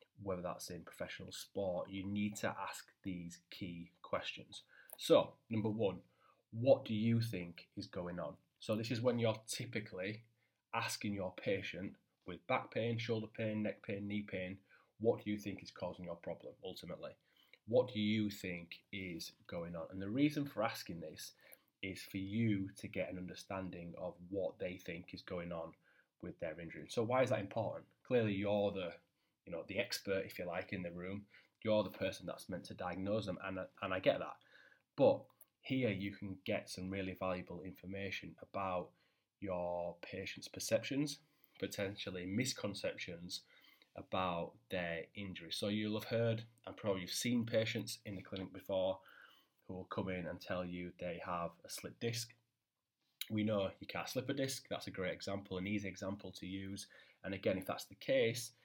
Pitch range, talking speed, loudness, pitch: 95-115 Hz, 180 wpm, -41 LUFS, 100 Hz